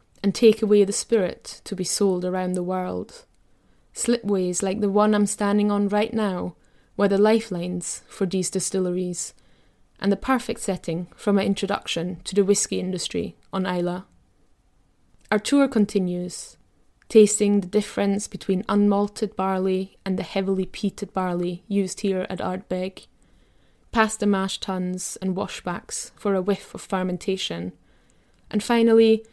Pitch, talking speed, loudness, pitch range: 195 Hz, 145 wpm, -23 LUFS, 185-205 Hz